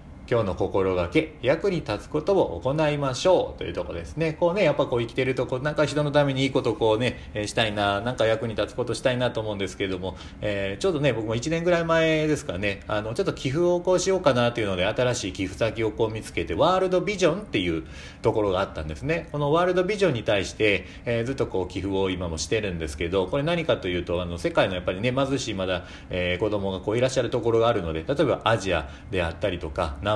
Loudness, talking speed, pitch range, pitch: -25 LUFS, 500 characters per minute, 95-145 Hz, 115 Hz